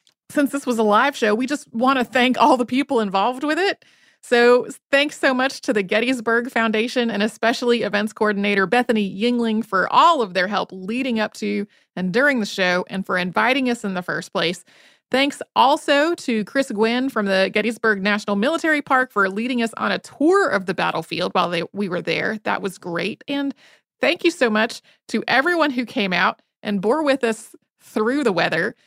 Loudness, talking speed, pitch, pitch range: -20 LUFS, 200 wpm, 230 Hz, 205-270 Hz